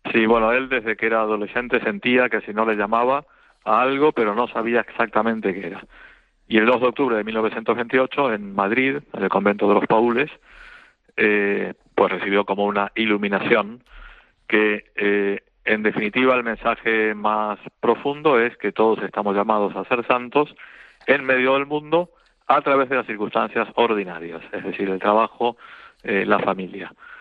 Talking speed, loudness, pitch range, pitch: 165 wpm, -20 LUFS, 100-125 Hz, 110 Hz